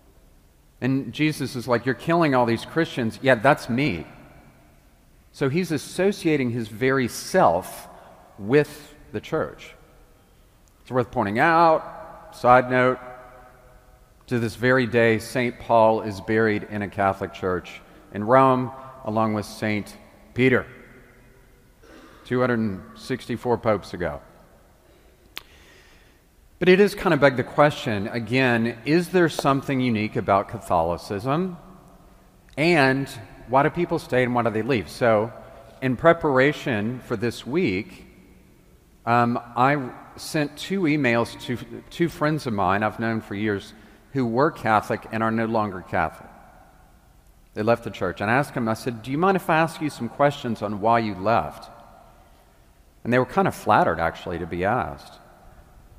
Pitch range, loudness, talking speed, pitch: 110-135 Hz, -23 LUFS, 145 wpm, 120 Hz